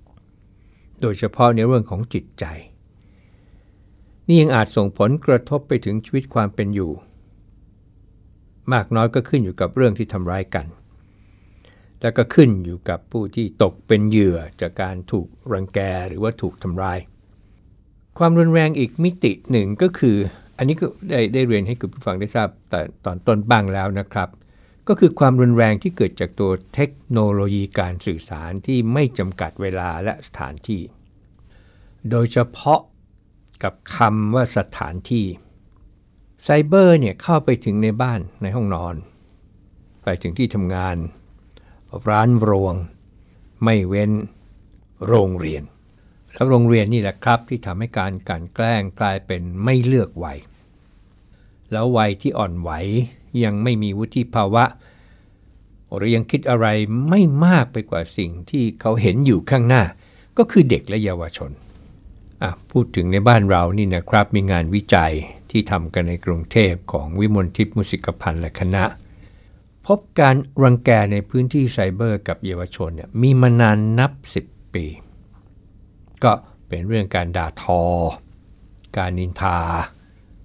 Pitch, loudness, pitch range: 100 Hz, -19 LUFS, 95-115 Hz